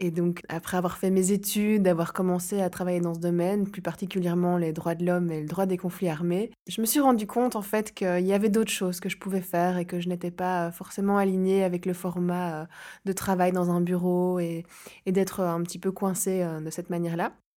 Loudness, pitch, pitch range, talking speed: -27 LUFS, 180 Hz, 175-195 Hz, 230 wpm